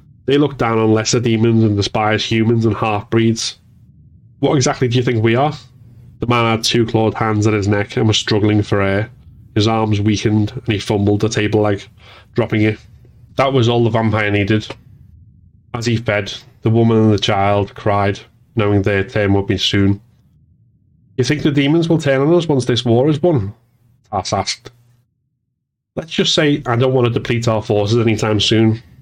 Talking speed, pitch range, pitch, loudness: 190 wpm, 105-125 Hz, 115 Hz, -16 LUFS